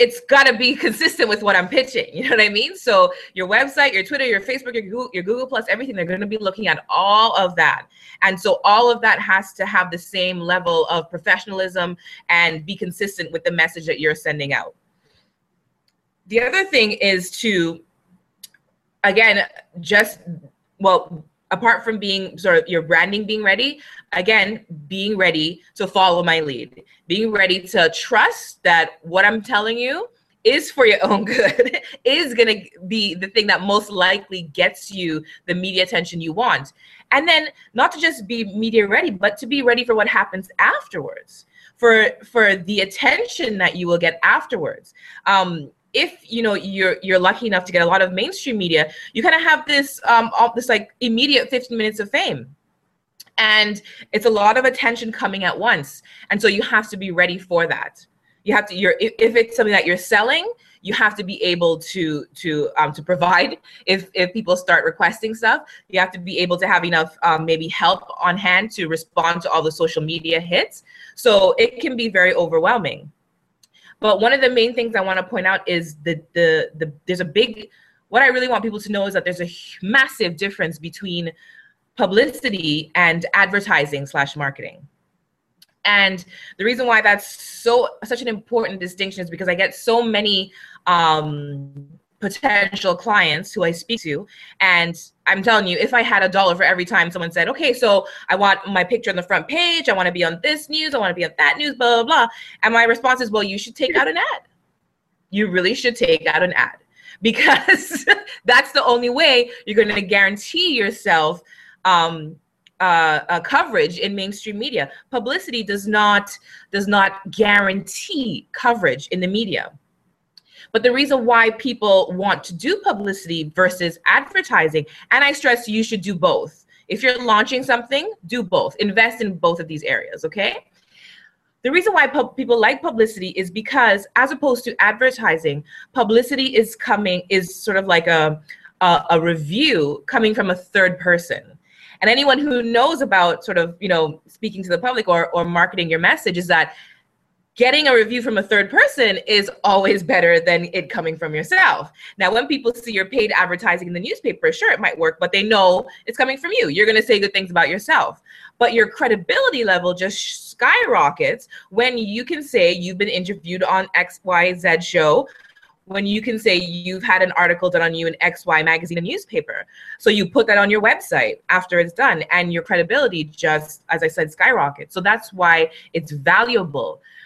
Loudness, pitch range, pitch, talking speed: -17 LUFS, 180-245 Hz, 205 Hz, 190 wpm